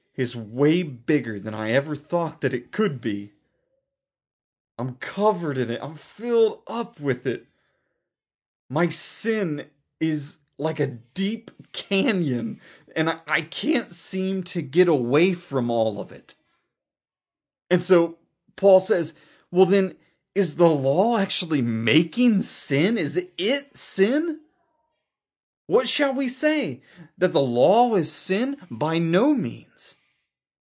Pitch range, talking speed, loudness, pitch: 145-215 Hz, 130 wpm, -23 LUFS, 175 Hz